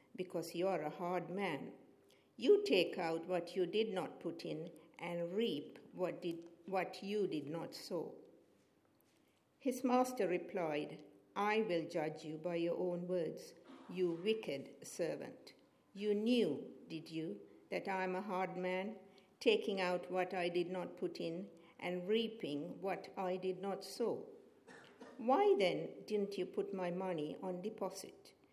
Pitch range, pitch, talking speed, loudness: 170-200 Hz, 185 Hz, 150 wpm, -40 LUFS